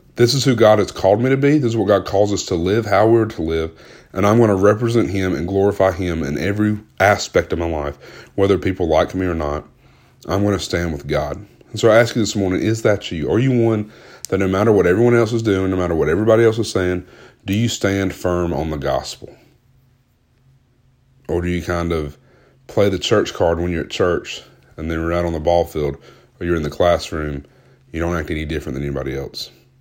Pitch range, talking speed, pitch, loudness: 85-115 Hz, 235 wpm, 95 Hz, -18 LUFS